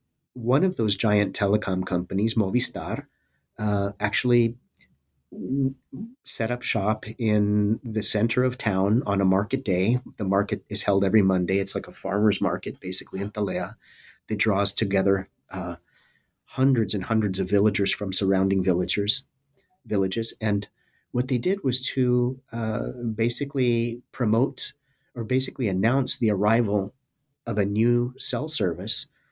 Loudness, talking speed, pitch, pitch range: -23 LUFS, 135 wpm, 110 Hz, 100-125 Hz